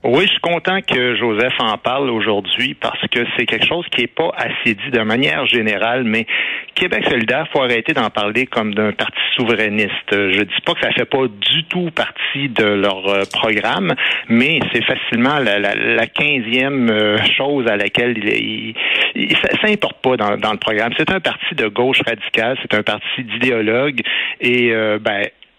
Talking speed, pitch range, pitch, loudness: 190 wpm, 105-135 Hz, 120 Hz, -16 LUFS